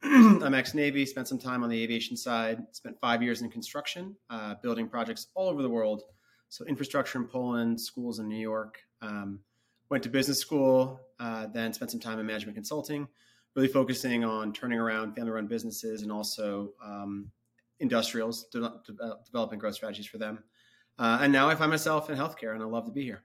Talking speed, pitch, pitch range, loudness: 200 wpm, 115 Hz, 110-135 Hz, -30 LUFS